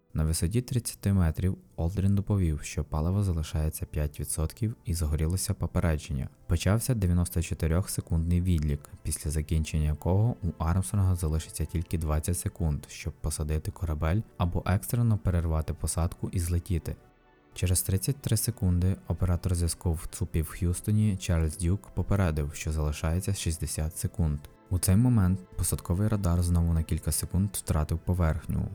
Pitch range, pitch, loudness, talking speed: 80-95 Hz, 85 Hz, -29 LUFS, 125 wpm